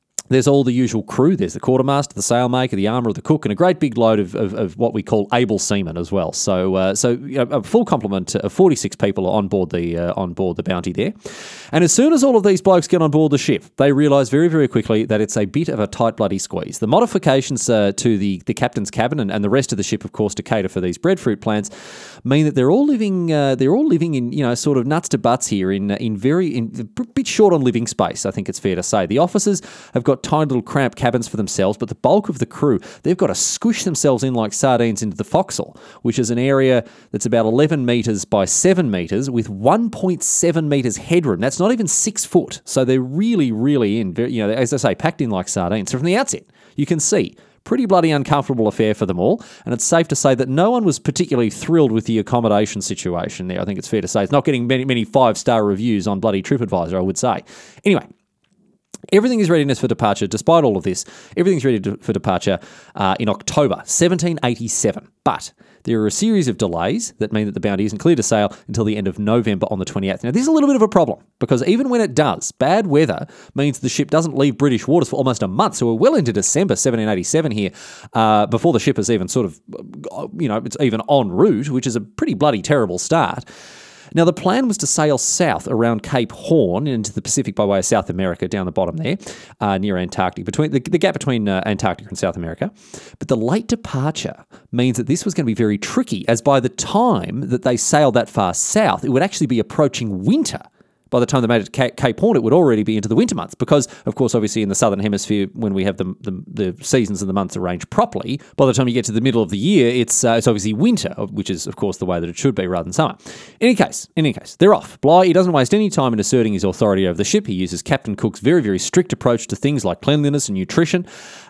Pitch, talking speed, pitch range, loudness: 125 Hz, 250 wpm, 105-155 Hz, -18 LUFS